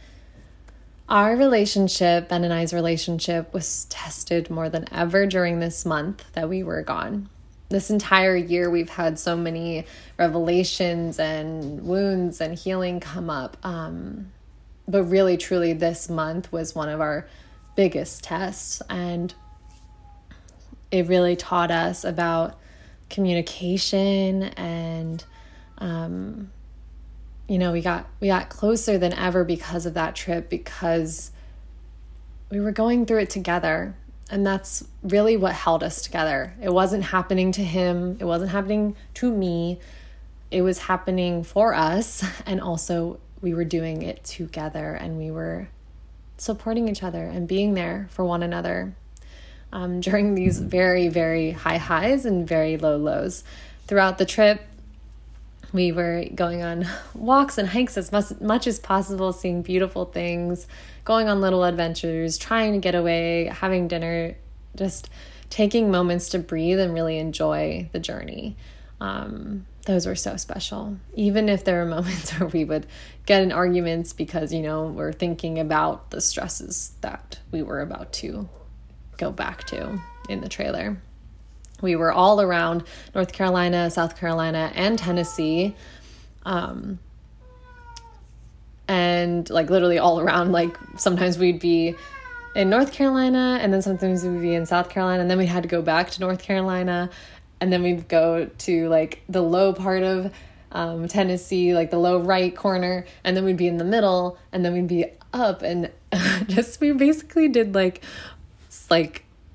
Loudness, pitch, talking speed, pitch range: -23 LUFS, 175 Hz, 150 wpm, 165-190 Hz